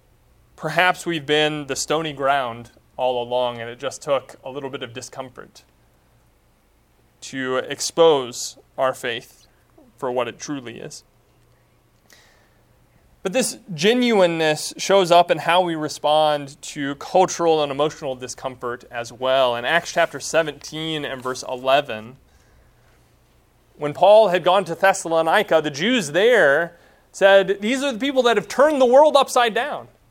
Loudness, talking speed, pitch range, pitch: -19 LUFS, 140 wpm, 130-185 Hz, 150 Hz